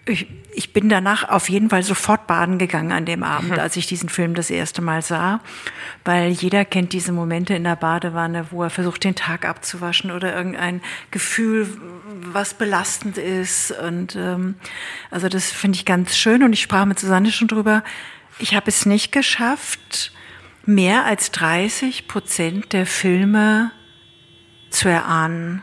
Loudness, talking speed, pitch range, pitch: -19 LUFS, 160 wpm, 175-210 Hz, 185 Hz